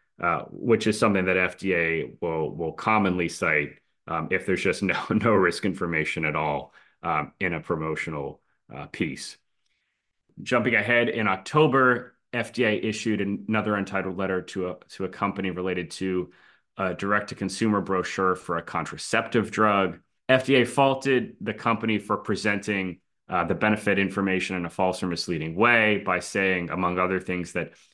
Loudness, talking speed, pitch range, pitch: -25 LUFS, 160 wpm, 90-110 Hz, 95 Hz